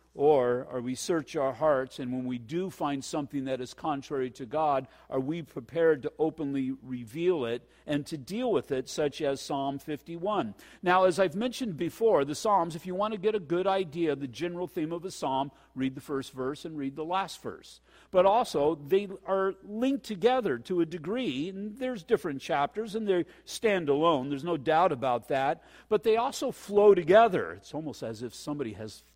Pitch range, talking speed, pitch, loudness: 140-195 Hz, 210 wpm, 165 Hz, -29 LUFS